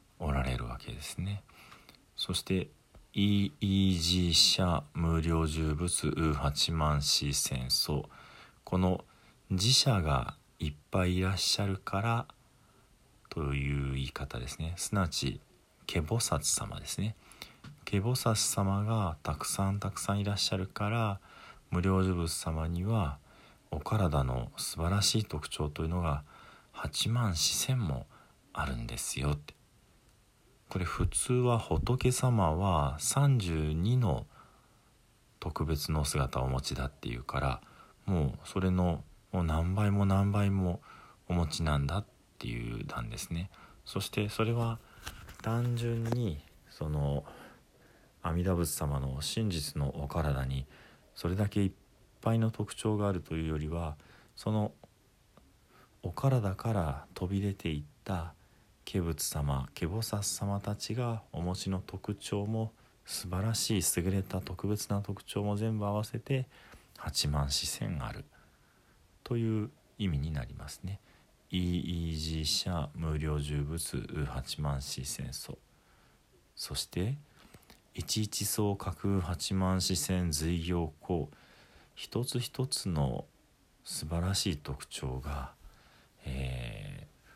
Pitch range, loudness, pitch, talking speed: 75-105 Hz, -33 LUFS, 90 Hz, 220 characters per minute